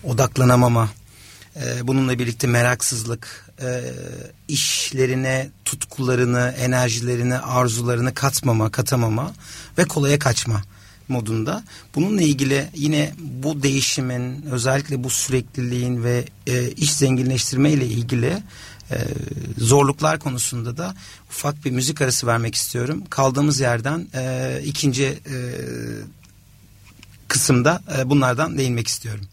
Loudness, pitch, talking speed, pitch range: -21 LUFS, 130 Hz, 90 wpm, 120-140 Hz